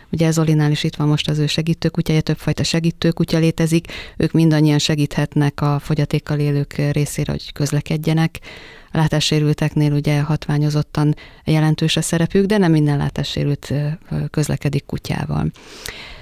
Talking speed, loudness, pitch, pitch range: 125 wpm, -18 LUFS, 150 Hz, 145-160 Hz